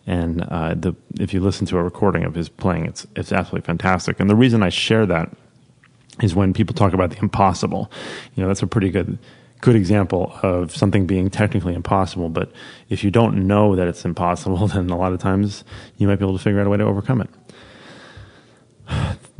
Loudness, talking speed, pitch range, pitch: -20 LUFS, 215 wpm, 90-105 Hz, 100 Hz